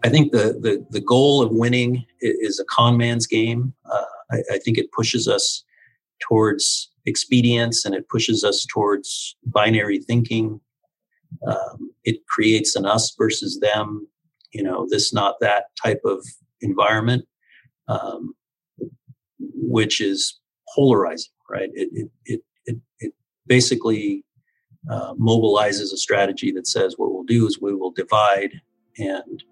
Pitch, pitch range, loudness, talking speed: 120 Hz, 105-130 Hz, -20 LUFS, 140 wpm